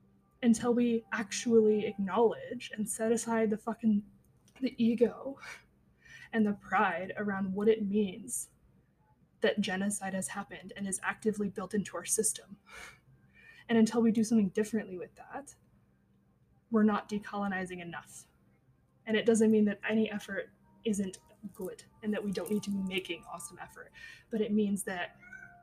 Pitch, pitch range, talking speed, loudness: 215 Hz, 200-225 Hz, 150 wpm, -32 LUFS